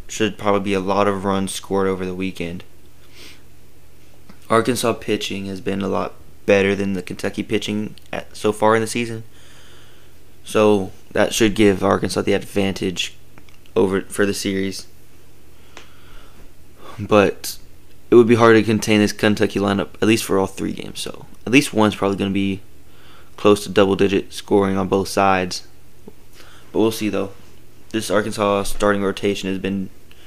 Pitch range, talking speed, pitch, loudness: 90-105 Hz, 160 wpm, 100 Hz, -19 LUFS